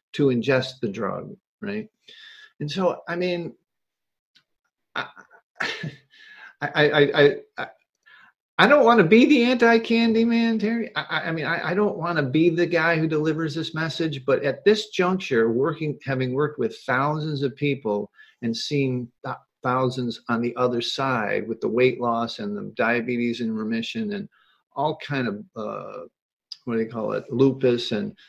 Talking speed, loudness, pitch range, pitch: 165 wpm, -23 LUFS, 125-205 Hz, 155 Hz